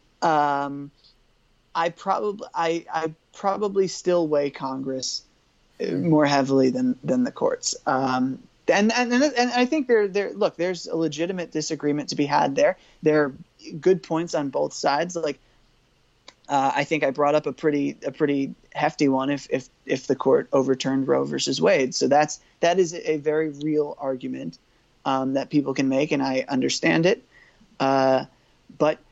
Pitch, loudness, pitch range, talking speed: 150 Hz, -23 LUFS, 135-170 Hz, 165 wpm